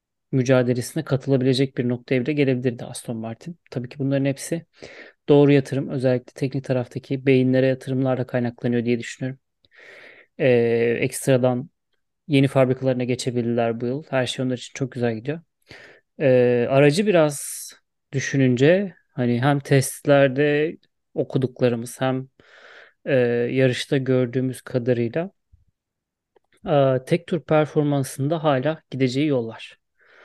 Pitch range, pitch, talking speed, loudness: 125-145 Hz, 130 Hz, 110 wpm, -22 LUFS